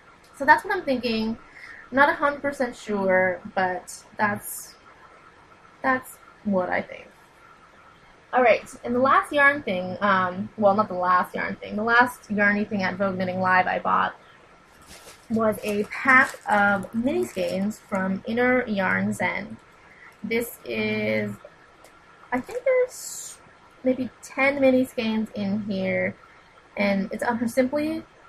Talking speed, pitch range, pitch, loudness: 140 wpm, 190-265 Hz, 220 Hz, -23 LUFS